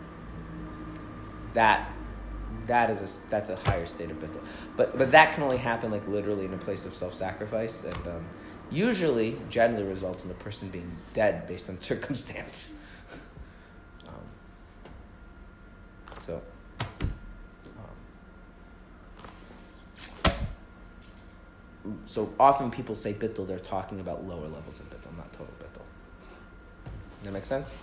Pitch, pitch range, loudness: 95 Hz, 85-105 Hz, -29 LUFS